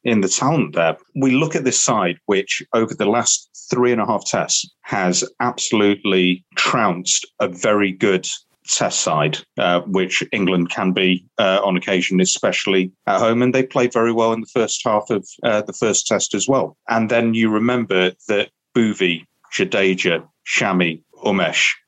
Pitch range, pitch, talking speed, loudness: 90-115 Hz, 100 Hz, 170 wpm, -18 LUFS